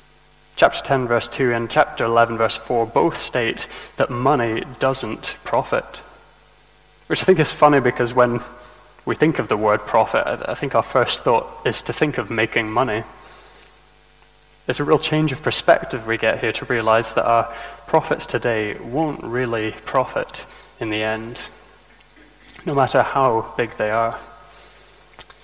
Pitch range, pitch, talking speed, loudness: 115-140 Hz, 120 Hz, 155 wpm, -20 LUFS